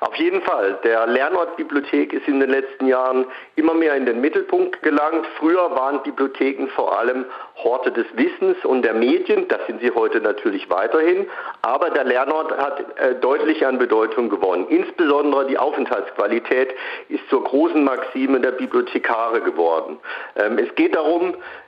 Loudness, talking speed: -19 LUFS, 155 wpm